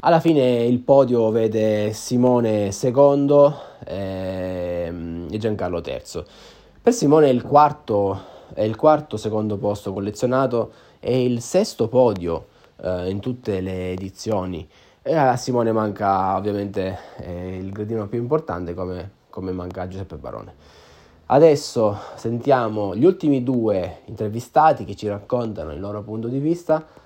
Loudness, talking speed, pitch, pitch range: -21 LUFS, 130 wpm, 110 Hz, 95-125 Hz